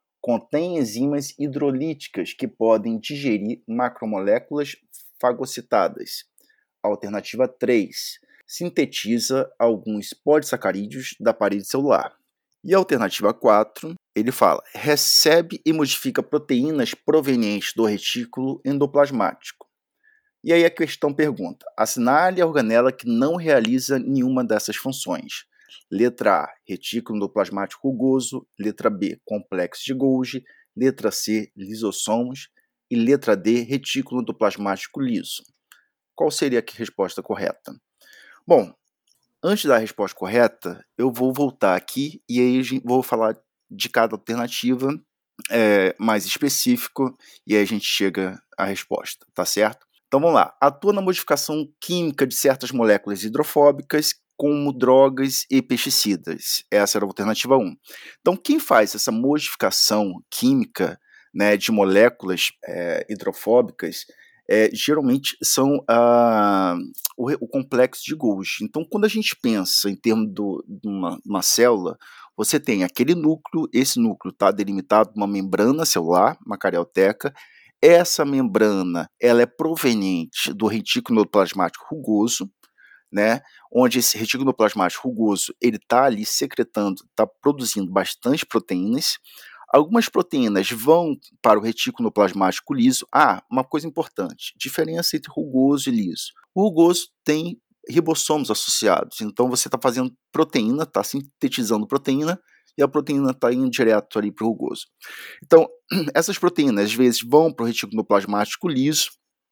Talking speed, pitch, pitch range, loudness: 125 wpm, 130 Hz, 110-155 Hz, -21 LUFS